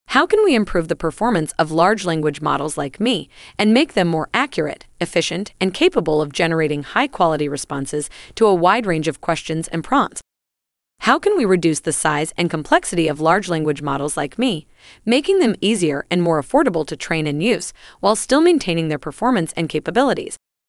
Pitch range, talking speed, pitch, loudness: 155-220 Hz, 185 wpm, 170 Hz, -18 LUFS